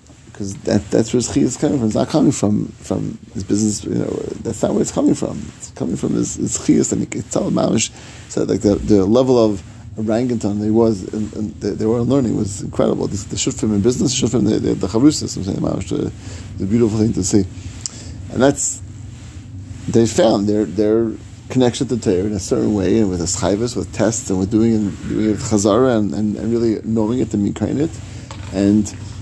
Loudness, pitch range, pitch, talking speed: -18 LUFS, 100-115 Hz, 105 Hz, 190 wpm